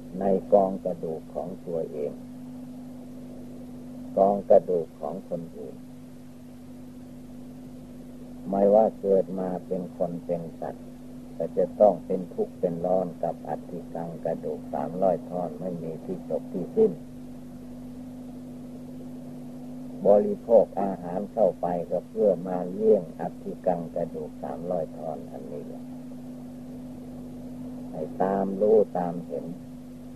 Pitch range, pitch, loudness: 95-125 Hz, 125 Hz, -27 LUFS